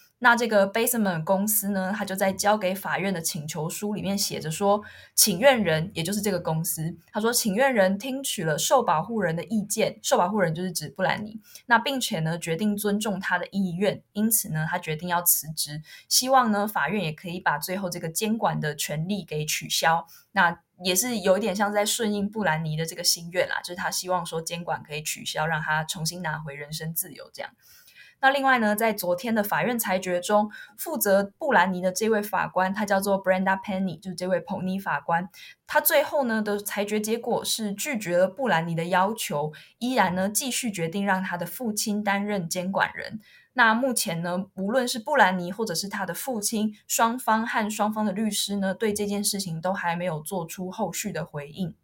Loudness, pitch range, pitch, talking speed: -25 LUFS, 175-215 Hz, 195 Hz, 315 characters per minute